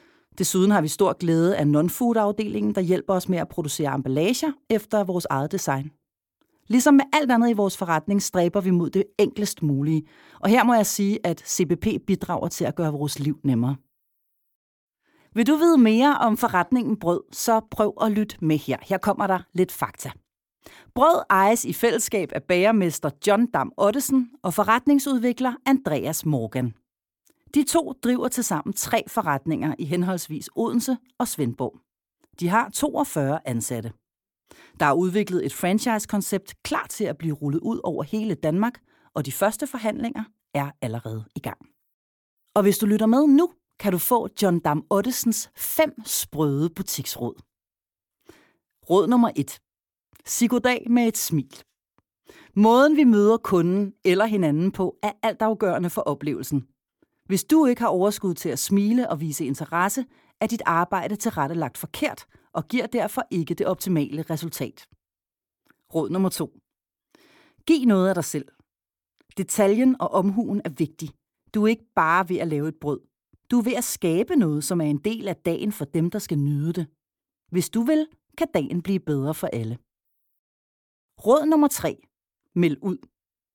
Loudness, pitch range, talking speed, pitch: -23 LUFS, 155-225 Hz, 160 wpm, 190 Hz